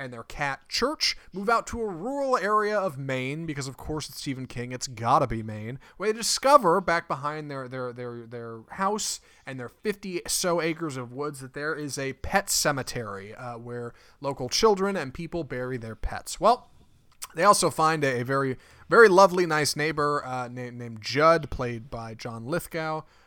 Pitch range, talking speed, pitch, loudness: 125-175 Hz, 185 wpm, 145 Hz, -26 LUFS